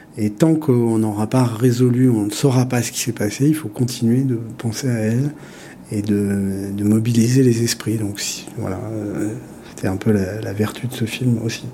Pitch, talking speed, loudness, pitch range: 115 Hz, 200 wpm, -19 LUFS, 105-125 Hz